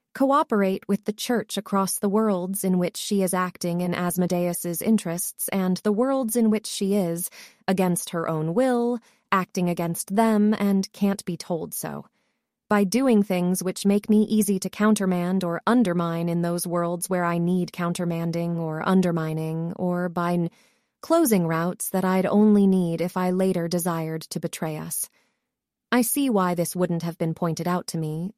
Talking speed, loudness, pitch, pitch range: 170 wpm, -24 LUFS, 185 Hz, 170-210 Hz